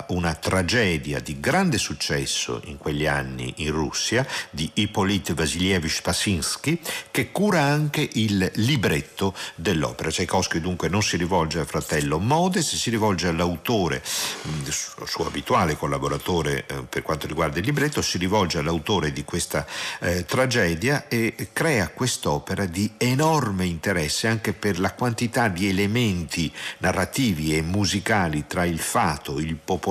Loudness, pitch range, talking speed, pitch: -24 LUFS, 80-110 Hz, 130 wpm, 90 Hz